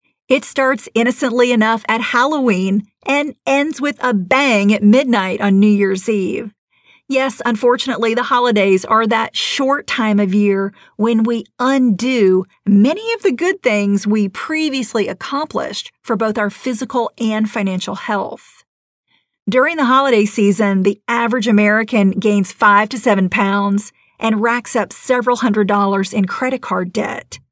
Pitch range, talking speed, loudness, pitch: 205-255 Hz, 145 wpm, -15 LUFS, 225 Hz